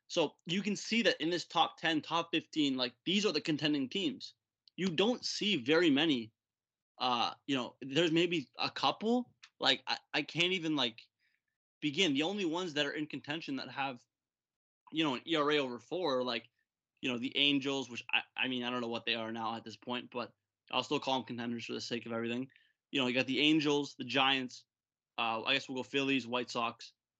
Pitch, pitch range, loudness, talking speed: 135 Hz, 120-155 Hz, -34 LUFS, 215 wpm